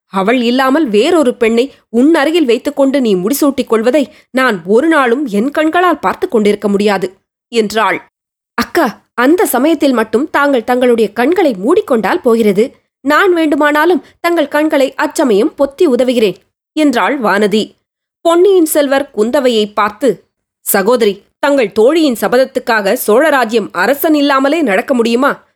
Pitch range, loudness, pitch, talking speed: 225-300 Hz, -11 LUFS, 265 Hz, 115 wpm